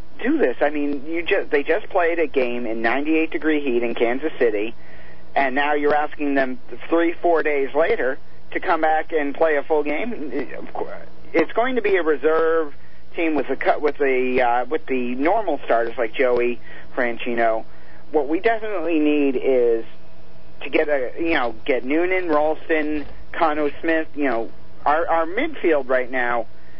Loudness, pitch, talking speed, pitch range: -21 LUFS, 150 Hz, 170 wpm, 130-165 Hz